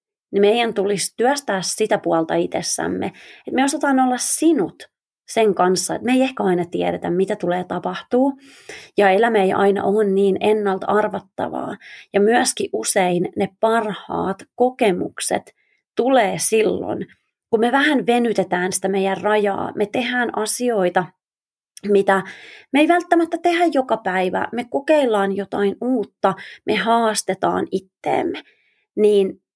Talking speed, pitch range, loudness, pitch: 130 wpm, 195-250 Hz, -19 LUFS, 210 Hz